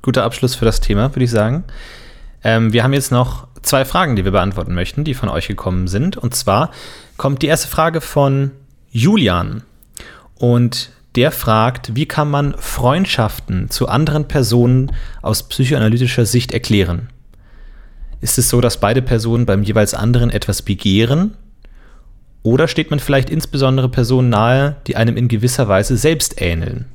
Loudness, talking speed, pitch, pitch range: -15 LUFS, 160 wpm, 125 Hz, 110-135 Hz